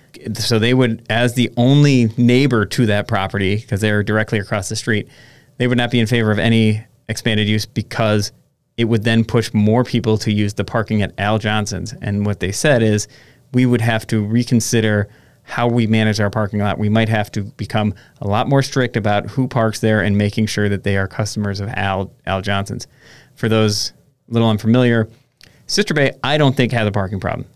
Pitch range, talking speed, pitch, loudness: 105-120 Hz, 205 wpm, 110 Hz, -17 LUFS